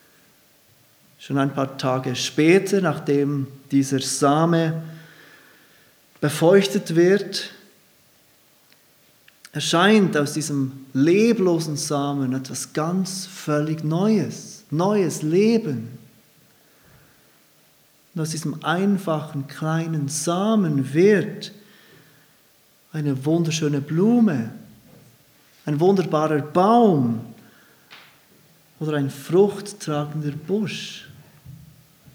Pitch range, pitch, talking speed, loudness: 145-185 Hz, 155 Hz, 70 wpm, -21 LUFS